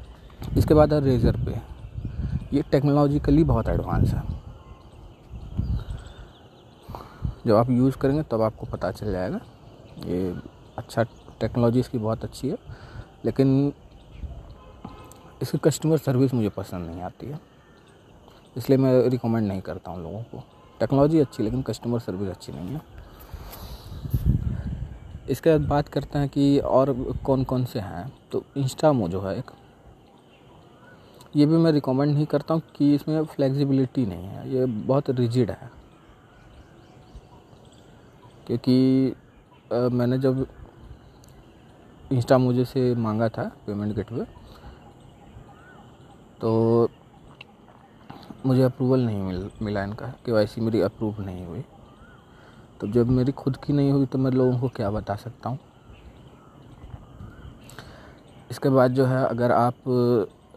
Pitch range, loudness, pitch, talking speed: 110-135 Hz, -24 LUFS, 125 Hz, 130 wpm